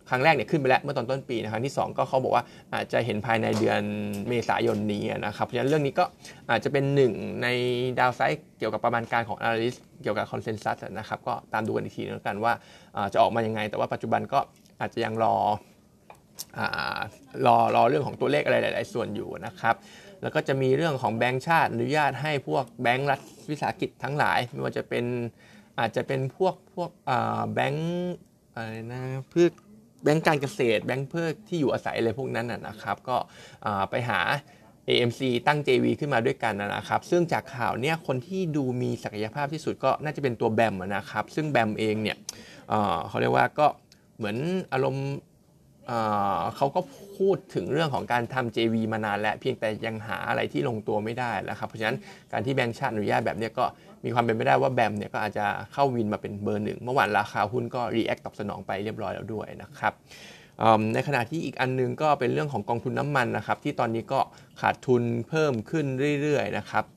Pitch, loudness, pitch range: 125 Hz, -27 LUFS, 115-145 Hz